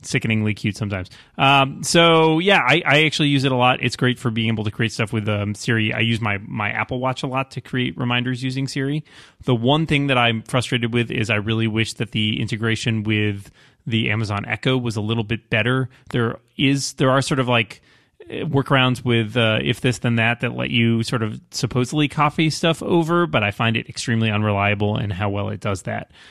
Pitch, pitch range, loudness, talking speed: 120 Hz, 110-135 Hz, -20 LUFS, 215 wpm